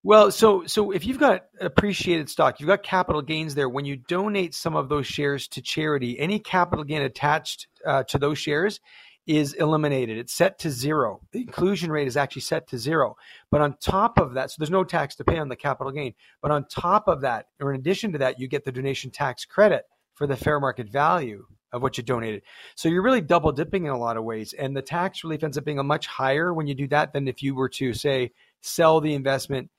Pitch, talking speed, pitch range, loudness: 150 Hz, 235 wpm, 135-175 Hz, -24 LUFS